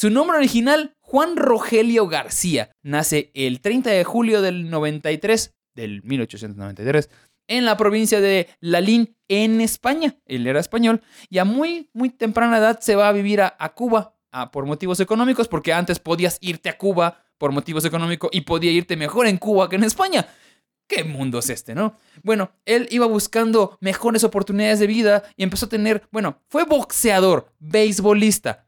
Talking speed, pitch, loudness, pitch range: 170 wpm, 205 Hz, -19 LUFS, 165-225 Hz